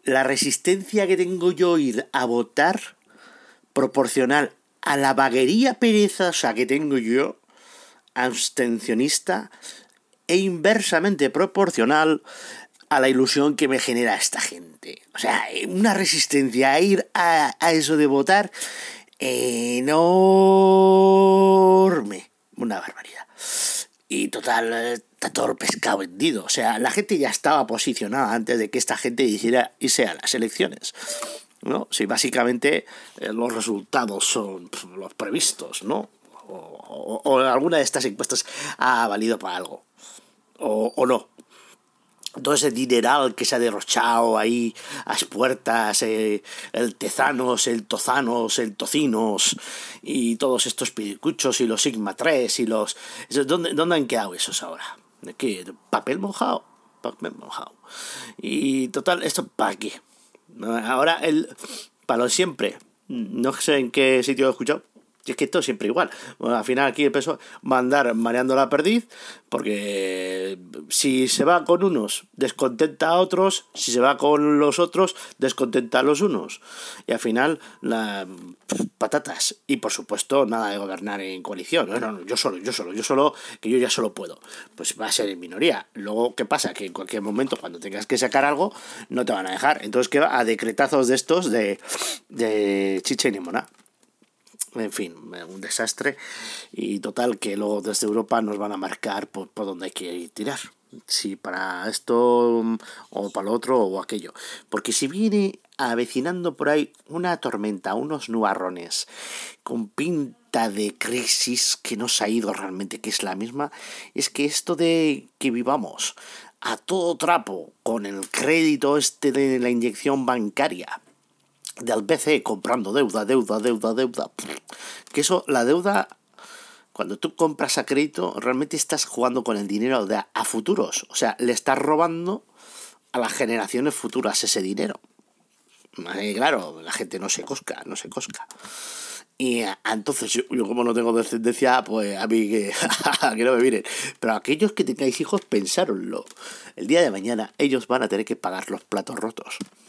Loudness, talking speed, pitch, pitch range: -22 LUFS, 160 wpm, 130 Hz, 115-160 Hz